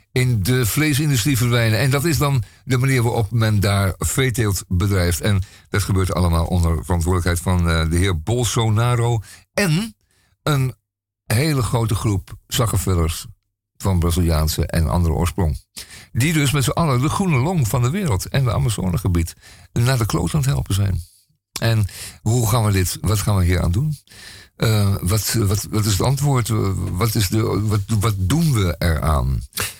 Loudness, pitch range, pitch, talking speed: -19 LUFS, 90-125 Hz, 105 Hz, 165 wpm